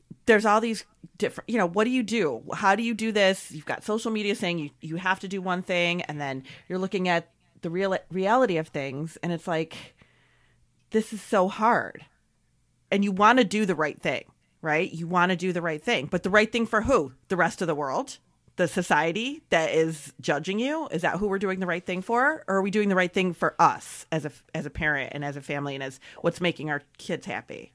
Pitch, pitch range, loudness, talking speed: 180 Hz, 160-210 Hz, -26 LUFS, 240 wpm